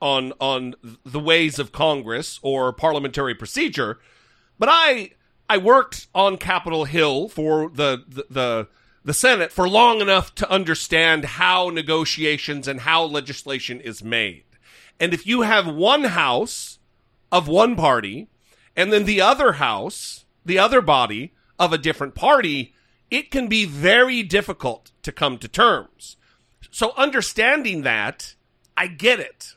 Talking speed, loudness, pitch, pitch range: 140 wpm, -19 LUFS, 160 Hz, 135-195 Hz